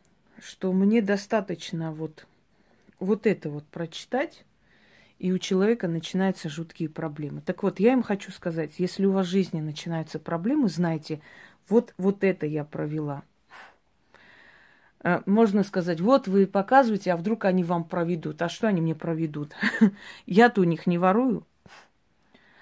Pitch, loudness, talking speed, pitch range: 185 Hz, -26 LUFS, 140 wpm, 165-205 Hz